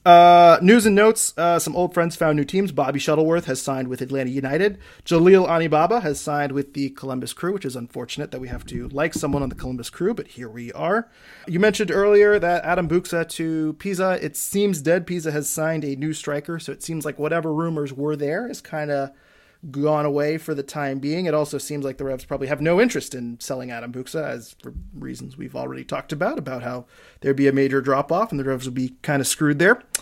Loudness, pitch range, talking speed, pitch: -21 LUFS, 135-170 Hz, 230 wpm, 150 Hz